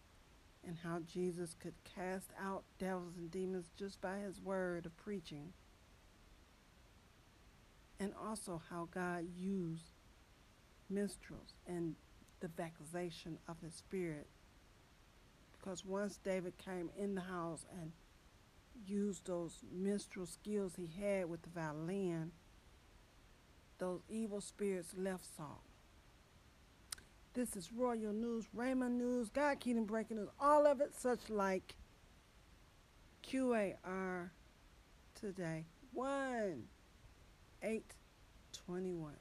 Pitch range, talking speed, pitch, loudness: 170-205 Hz, 105 wpm, 185 Hz, -43 LUFS